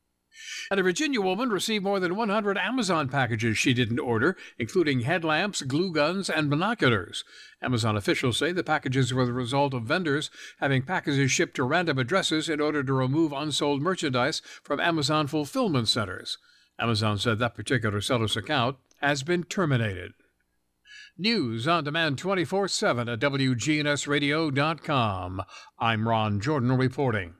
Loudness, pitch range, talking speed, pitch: -26 LUFS, 125-165 Hz, 140 wpm, 145 Hz